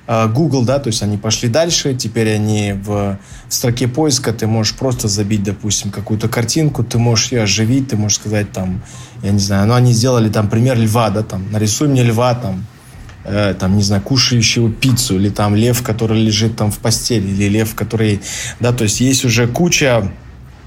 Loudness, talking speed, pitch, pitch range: -15 LUFS, 190 wpm, 110 Hz, 105-120 Hz